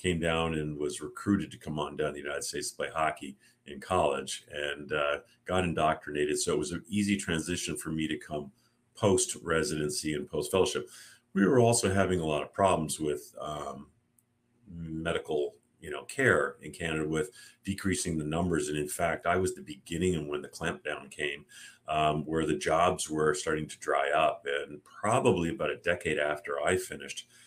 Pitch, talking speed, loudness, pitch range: 80 Hz, 190 wpm, -31 LUFS, 75-95 Hz